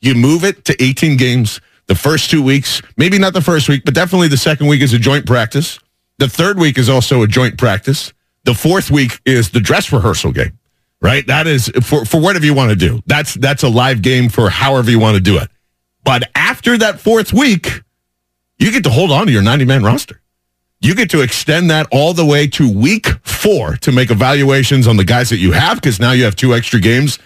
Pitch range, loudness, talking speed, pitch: 115-150 Hz, -11 LUFS, 225 wpm, 130 Hz